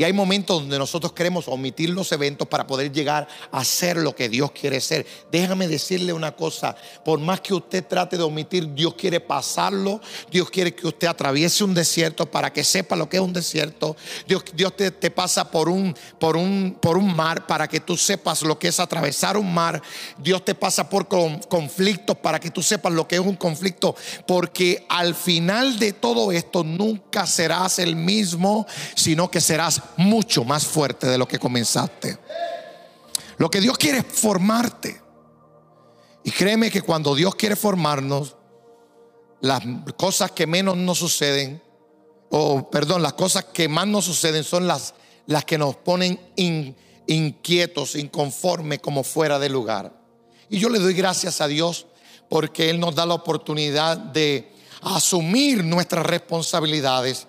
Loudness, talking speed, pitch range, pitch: -21 LUFS, 170 wpm, 155-190 Hz, 170 Hz